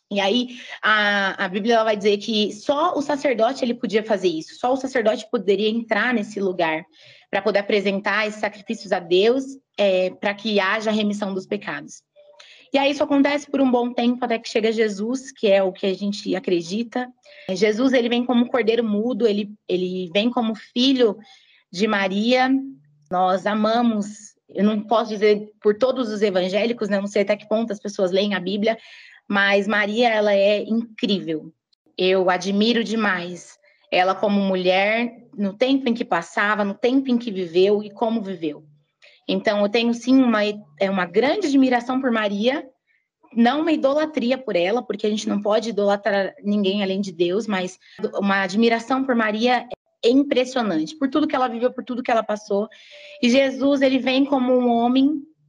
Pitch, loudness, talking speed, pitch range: 220 Hz, -21 LUFS, 180 wpm, 200-250 Hz